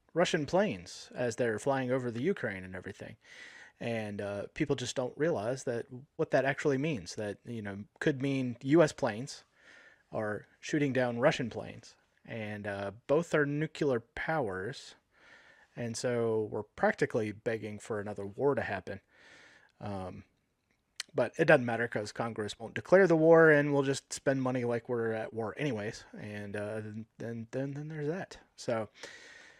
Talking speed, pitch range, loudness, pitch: 155 wpm, 105-150 Hz, -32 LUFS, 125 Hz